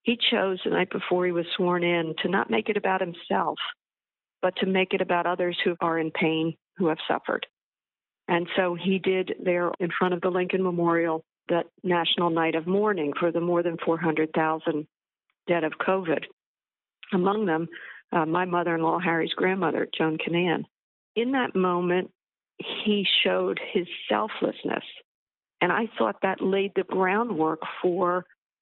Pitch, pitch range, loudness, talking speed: 175 Hz, 165-190 Hz, -26 LUFS, 160 wpm